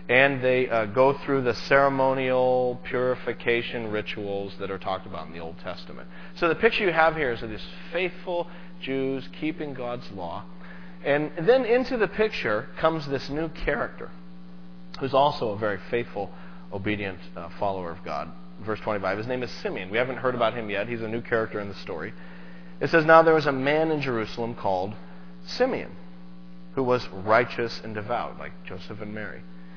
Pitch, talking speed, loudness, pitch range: 110 Hz, 180 wpm, -26 LUFS, 85-140 Hz